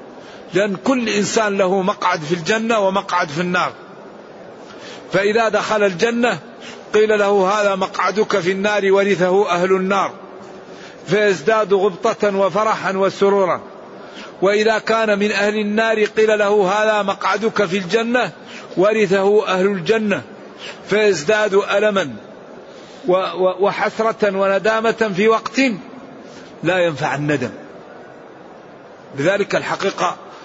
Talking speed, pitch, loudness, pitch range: 100 wpm, 205 Hz, -17 LUFS, 190-215 Hz